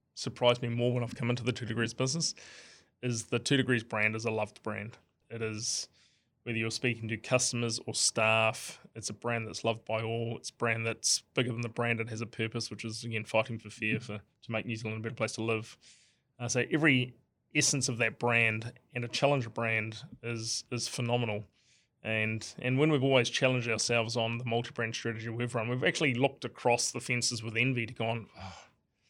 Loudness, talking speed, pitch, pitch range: -31 LUFS, 210 wpm, 115 Hz, 110-125 Hz